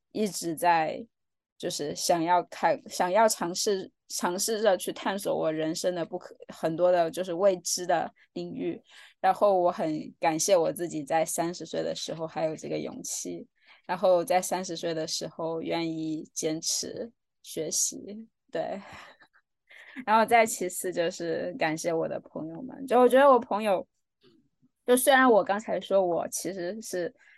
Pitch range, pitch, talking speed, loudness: 165-215 Hz, 180 Hz, 230 characters per minute, -27 LUFS